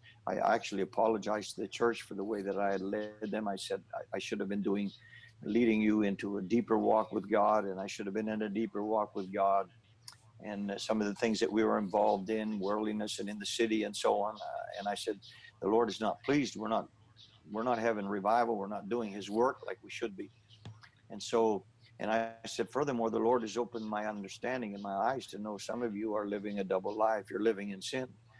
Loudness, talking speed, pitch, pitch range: -34 LUFS, 240 wpm, 105 Hz, 100-115 Hz